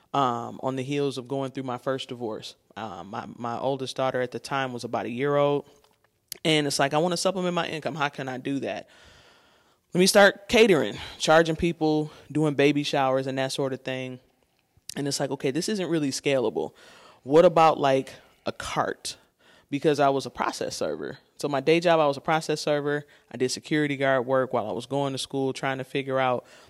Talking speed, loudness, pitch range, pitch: 215 wpm, -25 LUFS, 130-155 Hz, 140 Hz